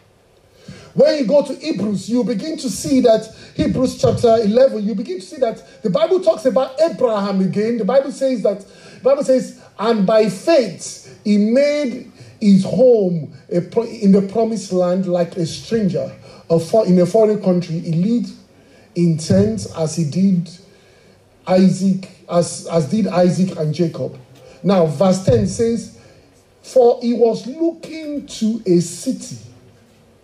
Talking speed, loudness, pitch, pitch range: 155 wpm, -17 LUFS, 205 Hz, 175-240 Hz